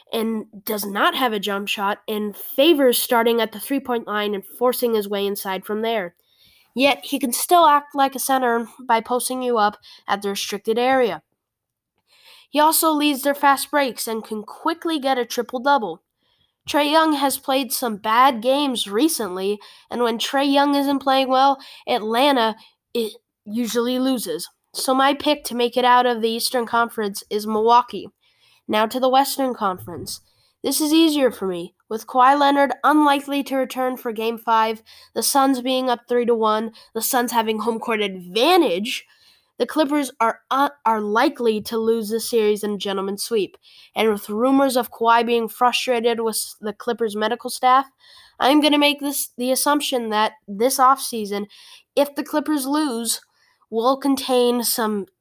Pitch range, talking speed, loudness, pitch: 220-275 Hz, 170 wpm, -20 LUFS, 245 Hz